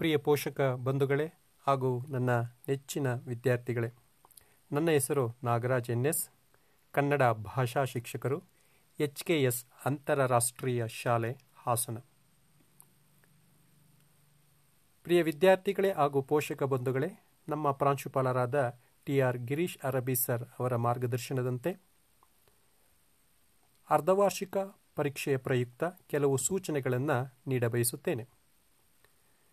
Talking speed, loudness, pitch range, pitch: 80 wpm, -31 LUFS, 125-150 Hz, 140 Hz